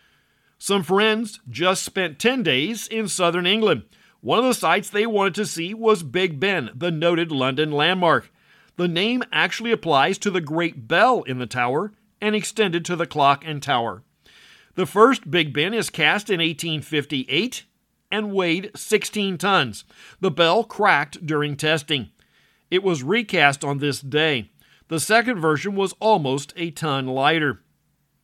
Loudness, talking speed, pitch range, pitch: -21 LUFS, 155 wpm, 150-205 Hz, 175 Hz